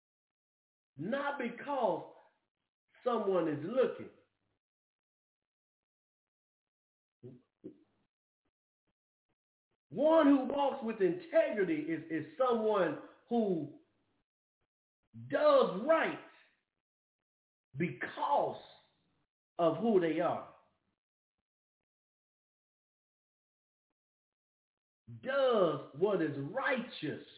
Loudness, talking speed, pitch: -33 LUFS, 55 wpm, 240 Hz